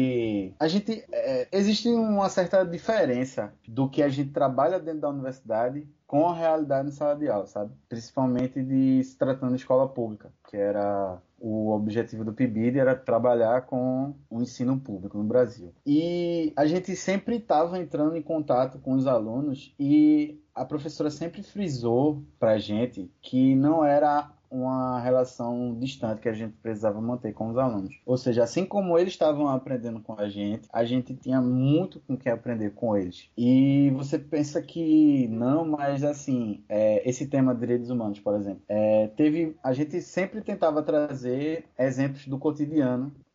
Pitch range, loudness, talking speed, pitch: 120-155 Hz, -26 LUFS, 165 wpm, 130 Hz